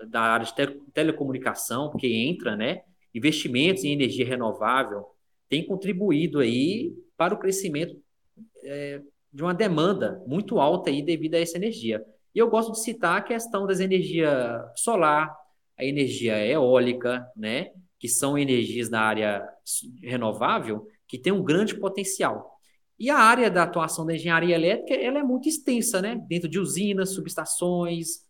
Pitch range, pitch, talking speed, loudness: 130-195 Hz, 165 Hz, 150 wpm, -25 LUFS